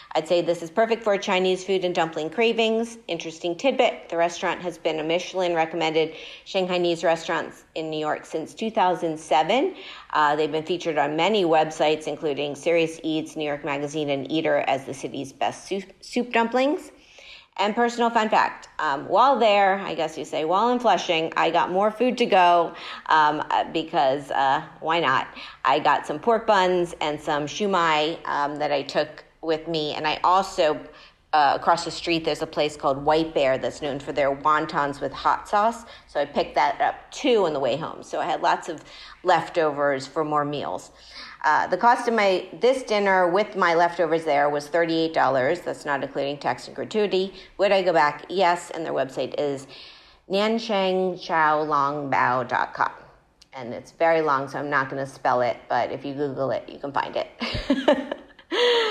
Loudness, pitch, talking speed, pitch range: -23 LUFS, 165 Hz, 180 wpm, 150-195 Hz